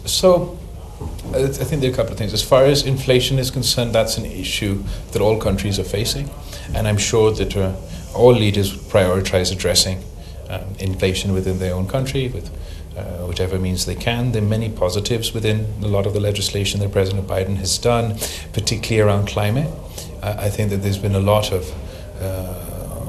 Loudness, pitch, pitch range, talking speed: -19 LUFS, 100 Hz, 95-110 Hz, 185 wpm